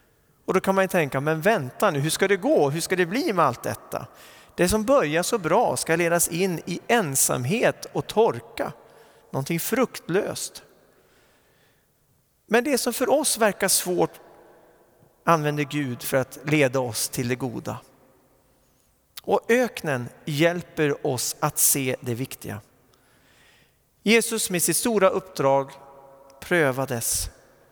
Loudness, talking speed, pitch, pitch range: -23 LUFS, 140 wpm, 165 Hz, 135-195 Hz